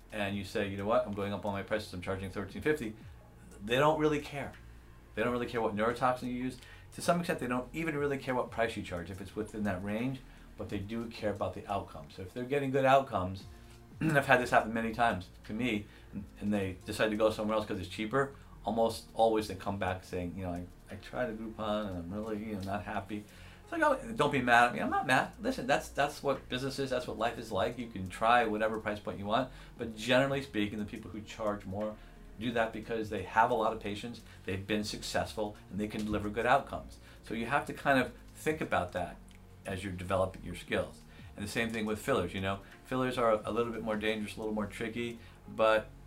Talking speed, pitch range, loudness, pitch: 240 wpm, 100-120 Hz, -33 LUFS, 110 Hz